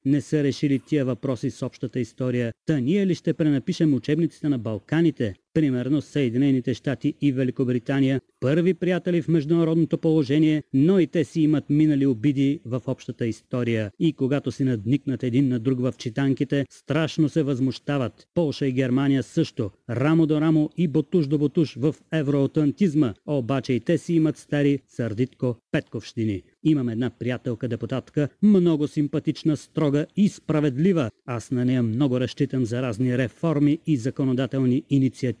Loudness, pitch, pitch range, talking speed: -23 LUFS, 140 Hz, 130-155 Hz, 150 wpm